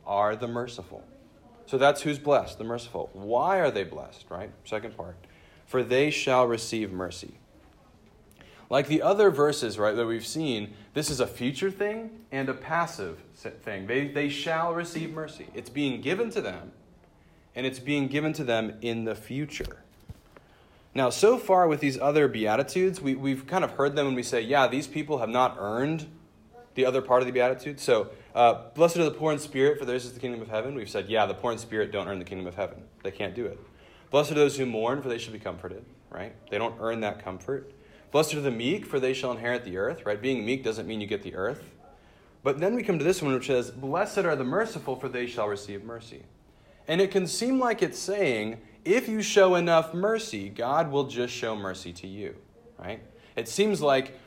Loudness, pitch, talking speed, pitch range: -27 LUFS, 130 Hz, 215 wpm, 115-155 Hz